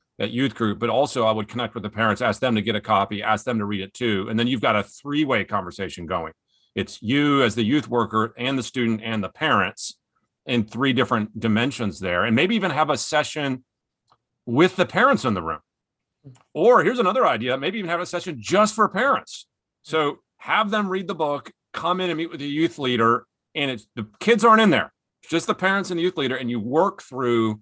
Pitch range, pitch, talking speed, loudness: 110-165 Hz, 130 Hz, 230 wpm, -22 LUFS